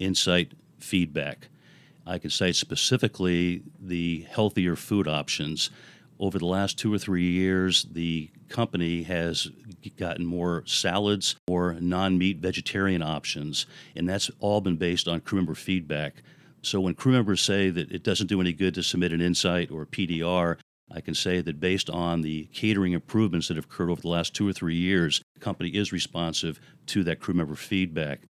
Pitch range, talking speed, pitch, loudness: 85-95 Hz, 175 wpm, 90 Hz, -27 LUFS